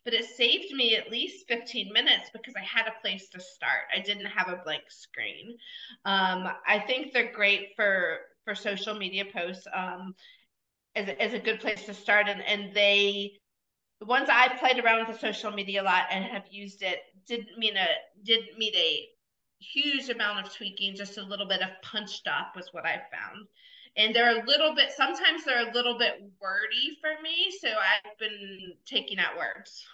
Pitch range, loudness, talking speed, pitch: 200-245 Hz, -27 LUFS, 195 wpm, 215 Hz